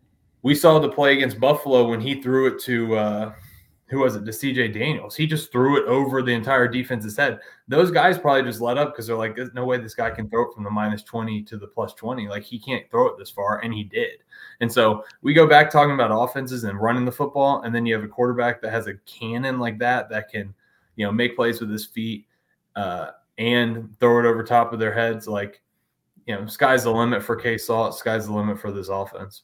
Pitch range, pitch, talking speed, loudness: 110-135 Hz, 120 Hz, 245 wpm, -21 LUFS